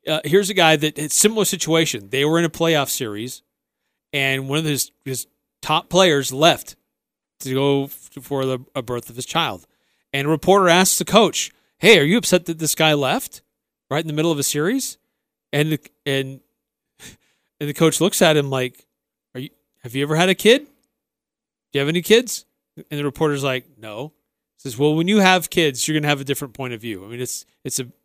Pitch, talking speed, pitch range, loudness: 150 Hz, 220 wpm, 135-170 Hz, -19 LUFS